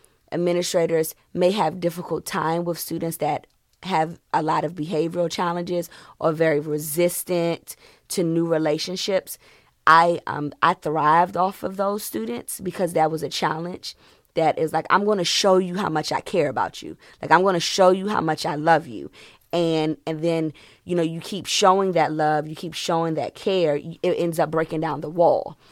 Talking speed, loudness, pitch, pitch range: 180 wpm, -22 LUFS, 165 Hz, 155-180 Hz